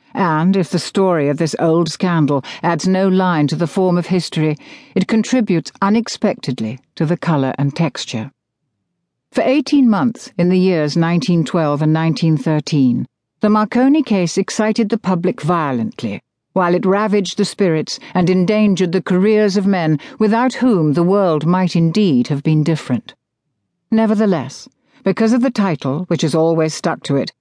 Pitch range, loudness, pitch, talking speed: 160-205 Hz, -16 LUFS, 180 Hz, 155 wpm